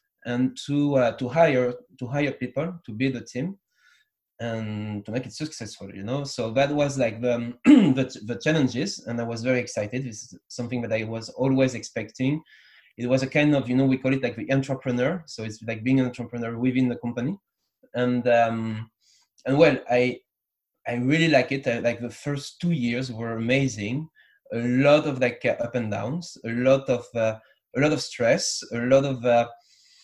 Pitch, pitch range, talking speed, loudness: 125 Hz, 115-135 Hz, 195 wpm, -24 LUFS